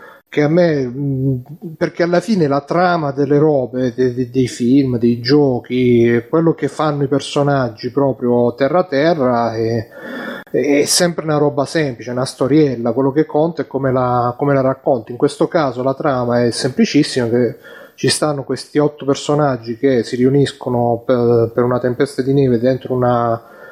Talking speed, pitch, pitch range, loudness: 160 wpm, 135 Hz, 125-150 Hz, -16 LUFS